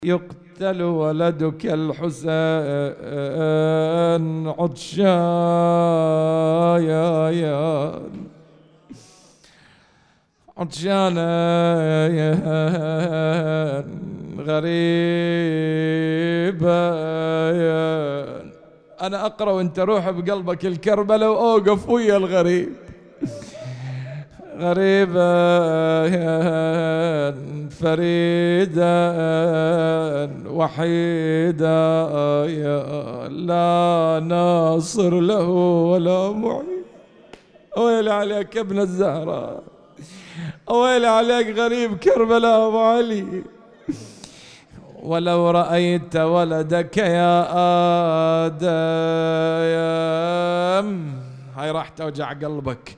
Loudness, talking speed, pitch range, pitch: -19 LUFS, 50 wpm, 160-180 Hz, 170 Hz